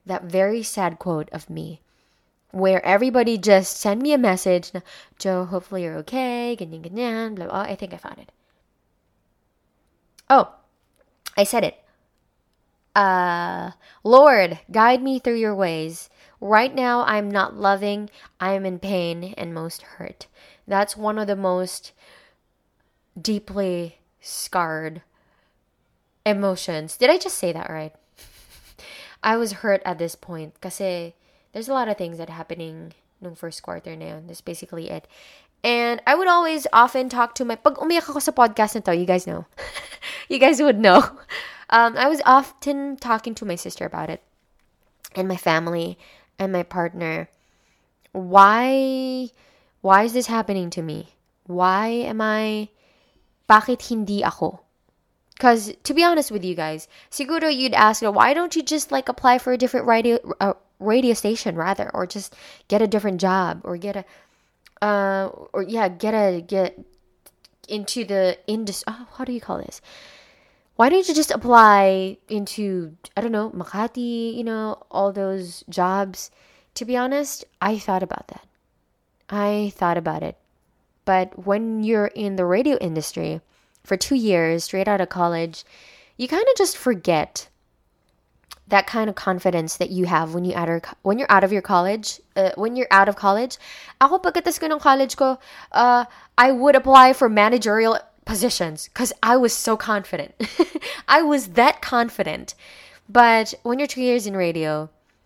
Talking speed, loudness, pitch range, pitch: 155 wpm, -20 LUFS, 180-245 Hz, 205 Hz